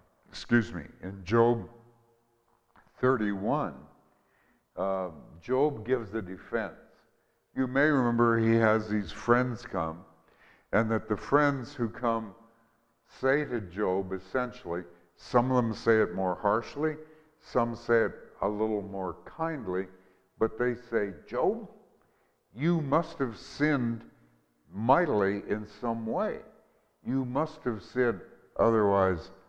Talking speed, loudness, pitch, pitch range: 120 wpm, -29 LUFS, 115 Hz, 95-125 Hz